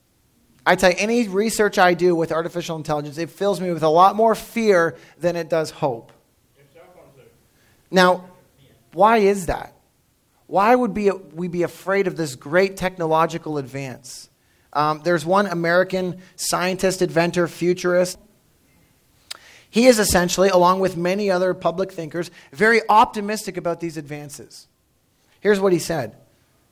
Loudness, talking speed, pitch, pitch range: -20 LUFS, 140 wpm, 175 Hz, 160-190 Hz